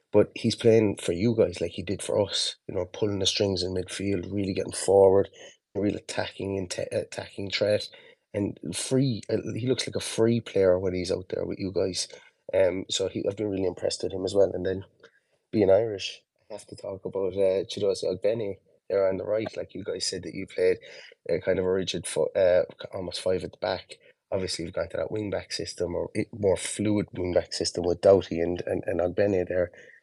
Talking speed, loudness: 220 wpm, -27 LUFS